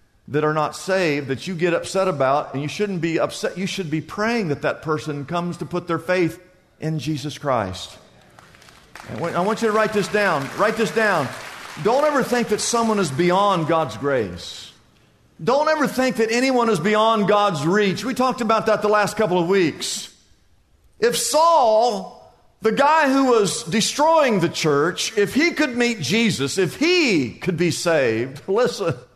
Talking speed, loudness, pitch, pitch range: 180 wpm, -20 LUFS, 195 Hz, 160-225 Hz